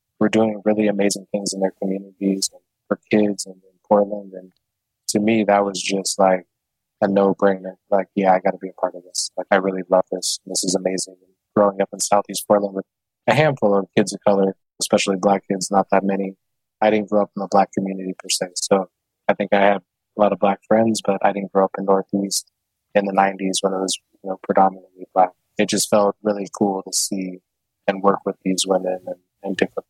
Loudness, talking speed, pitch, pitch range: -20 LUFS, 225 wpm, 100 Hz, 95-105 Hz